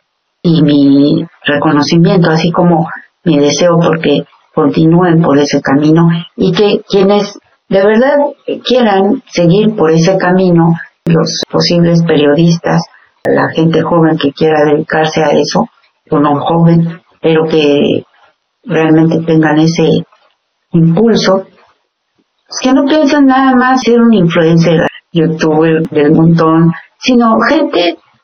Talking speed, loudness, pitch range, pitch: 120 wpm, -9 LUFS, 155-195 Hz, 165 Hz